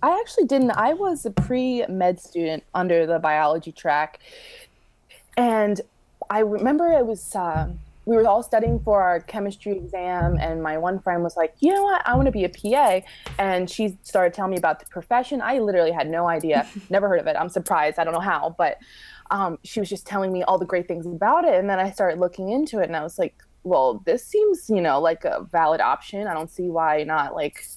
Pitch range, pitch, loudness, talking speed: 175-240 Hz, 195 Hz, -22 LUFS, 225 wpm